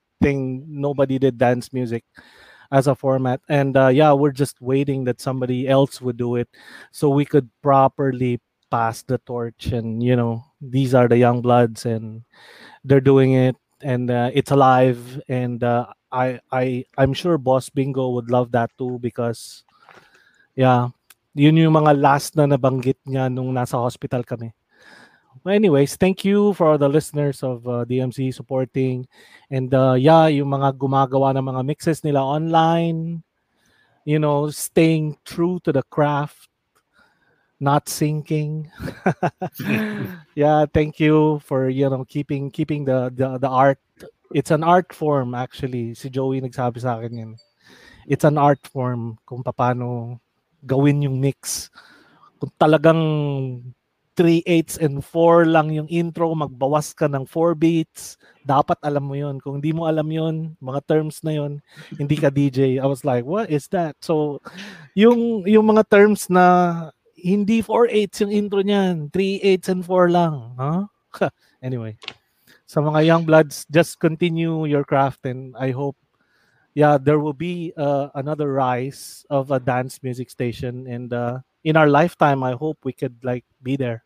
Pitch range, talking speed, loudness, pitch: 130-155 Hz, 160 wpm, -20 LUFS, 140 Hz